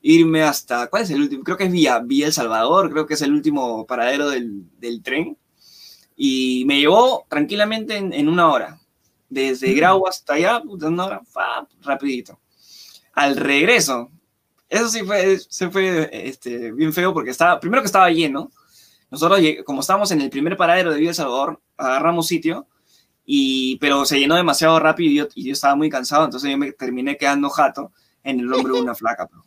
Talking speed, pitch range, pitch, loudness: 190 wpm, 135-185 Hz, 150 Hz, -18 LUFS